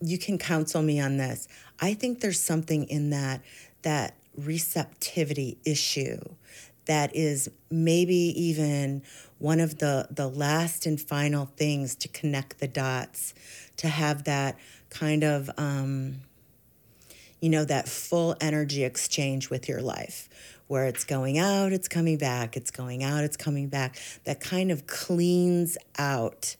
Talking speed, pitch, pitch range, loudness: 145 wpm, 150 Hz, 135-160 Hz, -28 LUFS